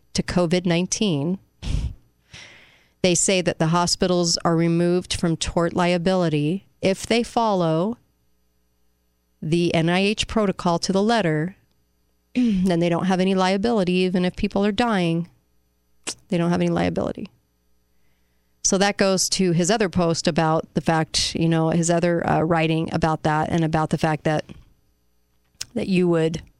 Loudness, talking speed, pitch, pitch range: -21 LUFS, 140 wpm, 170 Hz, 155-185 Hz